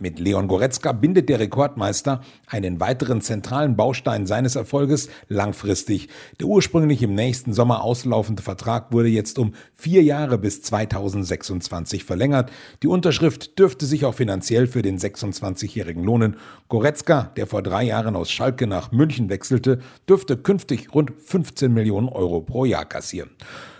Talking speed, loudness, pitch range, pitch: 145 wpm, -21 LUFS, 100-140 Hz, 120 Hz